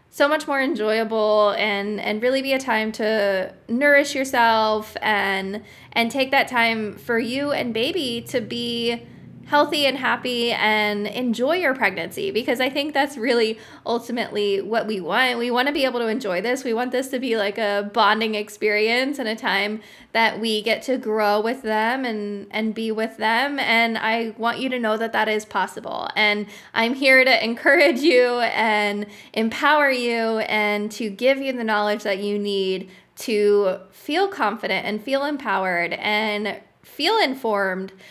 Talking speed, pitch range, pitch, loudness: 170 wpm, 210-255 Hz, 225 Hz, -21 LUFS